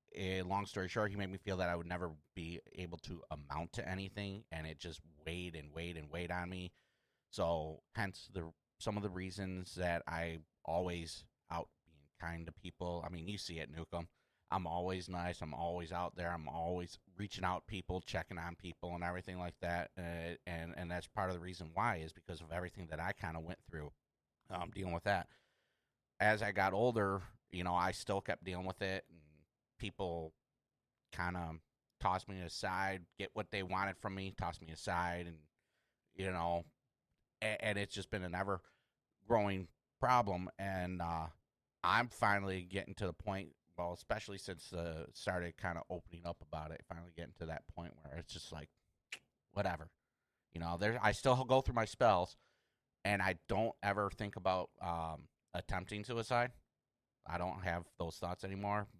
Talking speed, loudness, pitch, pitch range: 190 wpm, -41 LUFS, 90 Hz, 85-100 Hz